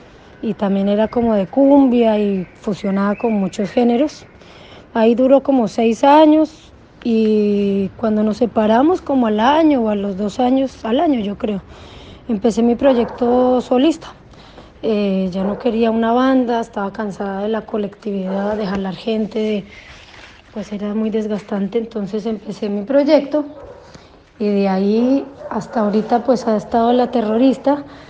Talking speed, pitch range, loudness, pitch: 145 wpm, 205-250 Hz, -17 LUFS, 225 Hz